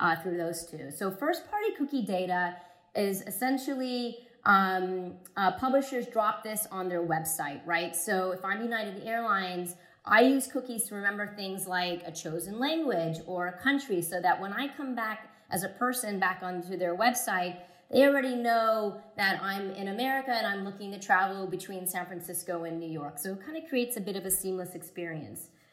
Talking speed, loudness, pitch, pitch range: 185 wpm, -30 LUFS, 195 Hz, 180-235 Hz